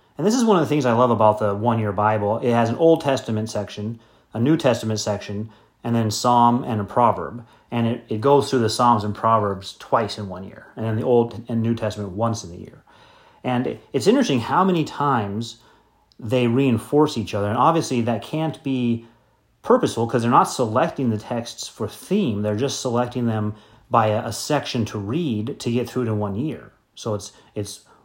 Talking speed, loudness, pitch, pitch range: 210 wpm, -21 LUFS, 115 Hz, 105-125 Hz